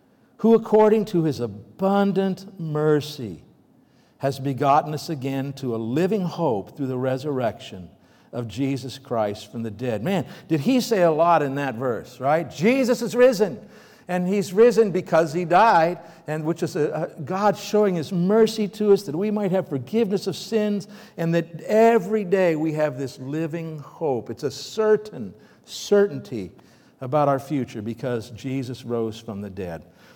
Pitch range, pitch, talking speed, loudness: 135-200 Hz, 165 Hz, 165 wpm, -22 LUFS